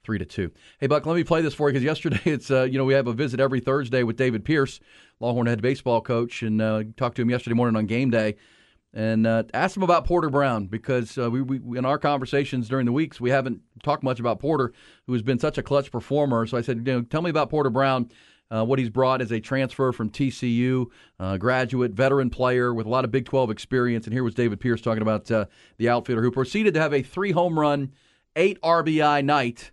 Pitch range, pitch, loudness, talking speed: 120-140 Hz, 130 Hz, -24 LUFS, 245 wpm